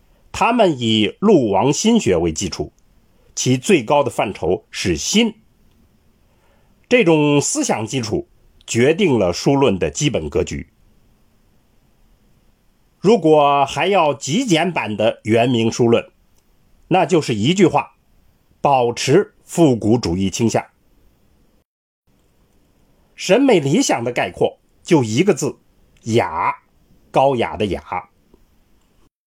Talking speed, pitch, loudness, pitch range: 155 characters per minute, 115 Hz, -17 LUFS, 90-150 Hz